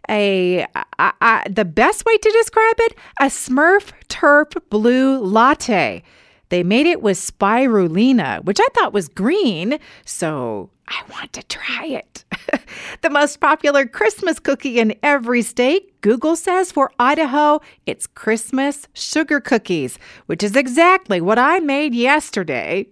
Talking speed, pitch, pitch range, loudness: 140 wpm, 280 Hz, 225-330 Hz, -16 LUFS